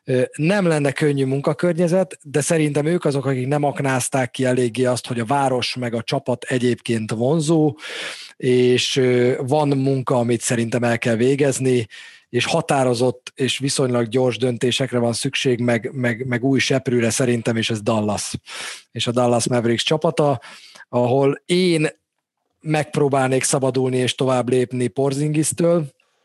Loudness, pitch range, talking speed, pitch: -20 LUFS, 120-145 Hz, 135 wpm, 130 Hz